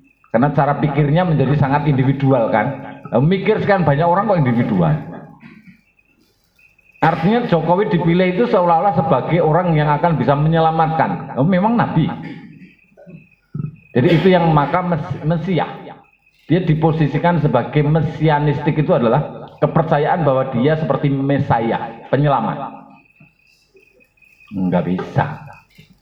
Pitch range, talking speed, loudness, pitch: 140-175 Hz, 105 wpm, -16 LUFS, 155 Hz